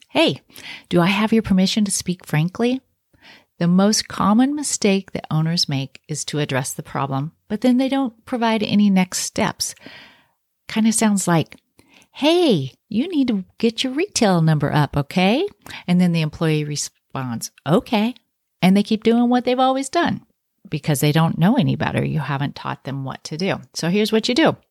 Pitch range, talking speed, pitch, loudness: 155-230 Hz, 180 wpm, 195 Hz, -20 LUFS